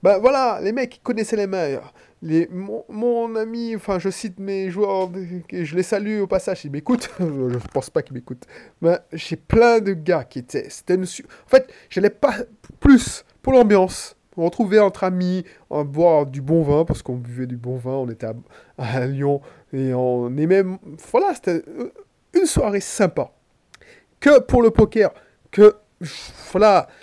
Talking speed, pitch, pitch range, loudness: 180 wpm, 190 Hz, 155-225 Hz, -20 LUFS